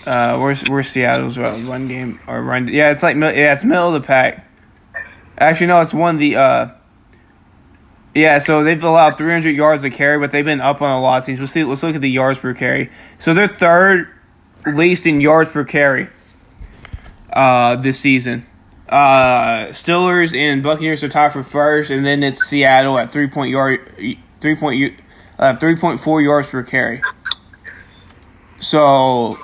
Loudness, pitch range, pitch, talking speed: -14 LUFS, 130-155 Hz, 140 Hz, 175 wpm